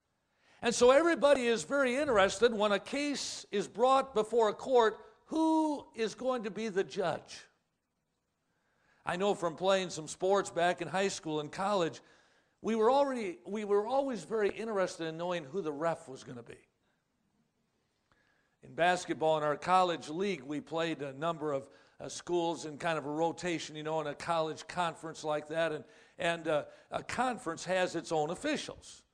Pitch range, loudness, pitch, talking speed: 160-220 Hz, -32 LUFS, 180 Hz, 175 wpm